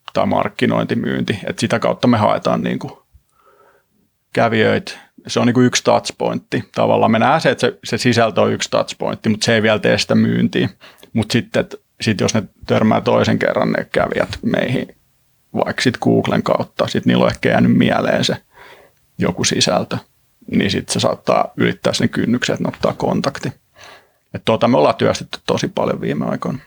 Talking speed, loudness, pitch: 165 wpm, -17 LUFS, 110 Hz